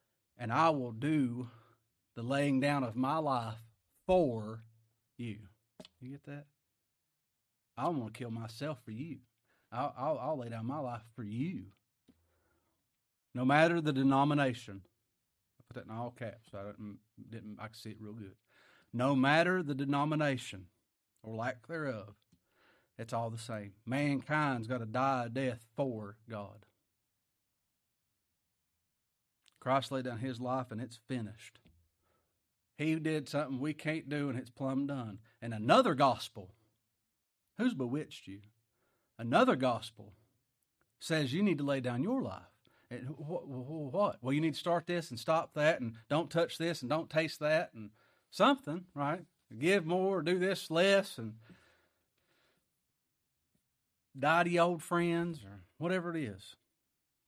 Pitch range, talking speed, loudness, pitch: 110-150 Hz, 150 wpm, -34 LUFS, 125 Hz